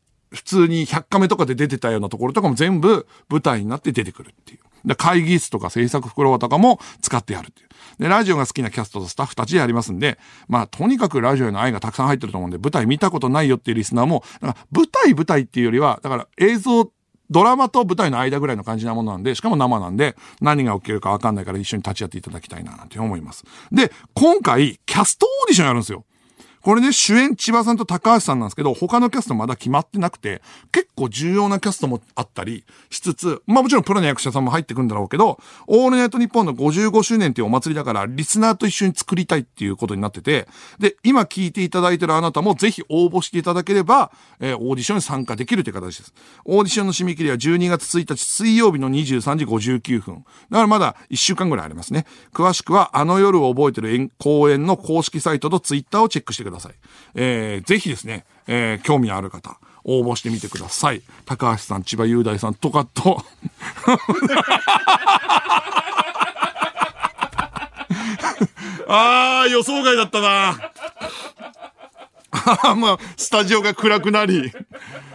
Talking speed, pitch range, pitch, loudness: 425 characters per minute, 120-205 Hz, 150 Hz, -18 LUFS